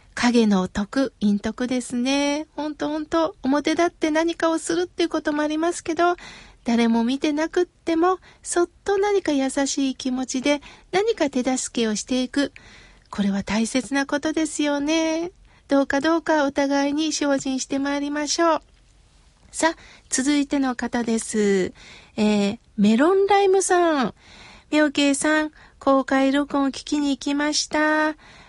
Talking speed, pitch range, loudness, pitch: 280 characters per minute, 260-320 Hz, -22 LUFS, 290 Hz